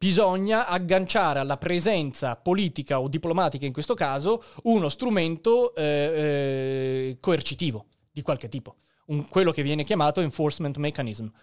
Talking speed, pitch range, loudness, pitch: 130 wpm, 140-185 Hz, -25 LUFS, 150 Hz